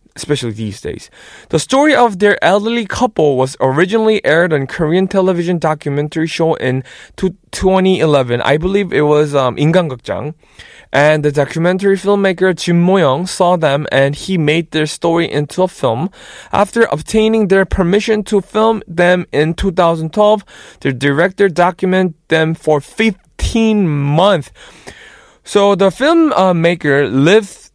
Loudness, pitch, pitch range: -13 LUFS, 175 Hz, 150-200 Hz